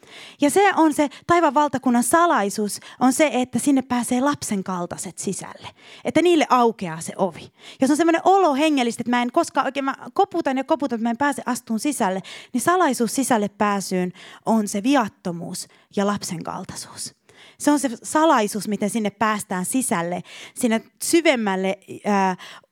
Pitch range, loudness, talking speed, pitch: 200-290 Hz, -21 LUFS, 165 wpm, 240 Hz